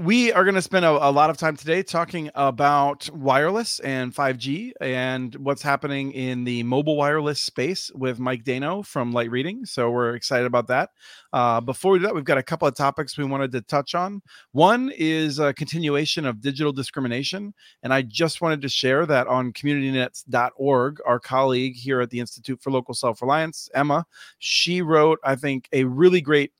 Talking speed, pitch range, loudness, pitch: 190 wpm, 130-160 Hz, -22 LUFS, 140 Hz